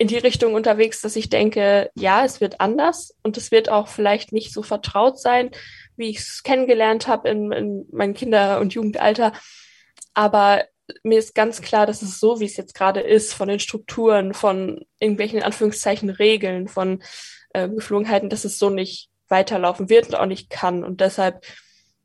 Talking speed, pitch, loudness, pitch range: 180 wpm, 210 Hz, -20 LUFS, 200-220 Hz